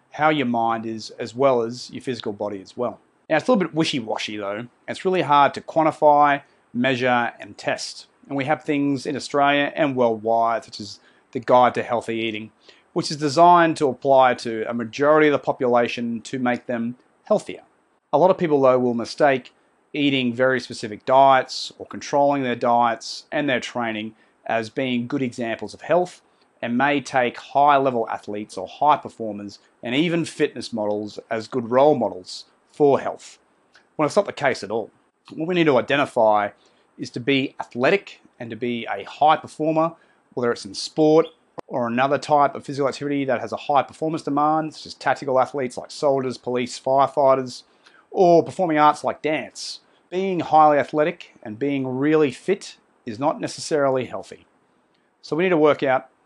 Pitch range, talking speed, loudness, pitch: 120-150 Hz, 180 wpm, -21 LUFS, 130 Hz